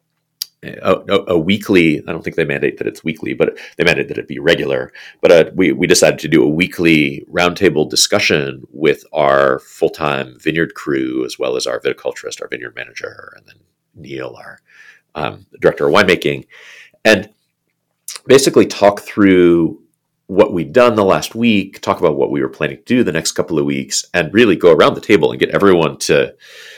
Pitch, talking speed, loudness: 360 Hz, 190 wpm, -14 LUFS